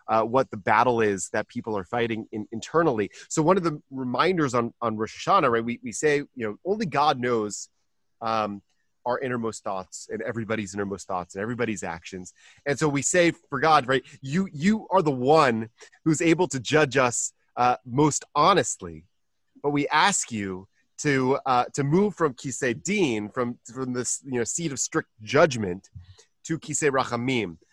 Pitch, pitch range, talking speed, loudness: 125 Hz, 110-150 Hz, 180 wpm, -25 LUFS